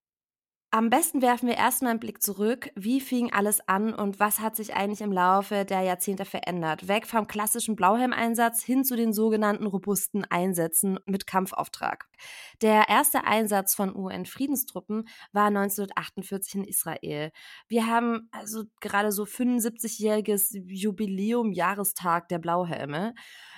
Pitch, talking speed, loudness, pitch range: 210 Hz, 130 wpm, -26 LUFS, 195-230 Hz